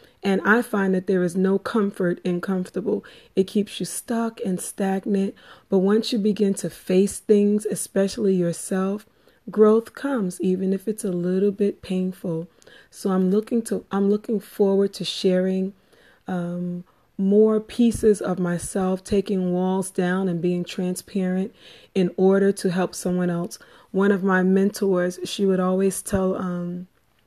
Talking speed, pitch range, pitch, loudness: 150 wpm, 185-205 Hz, 190 Hz, -23 LUFS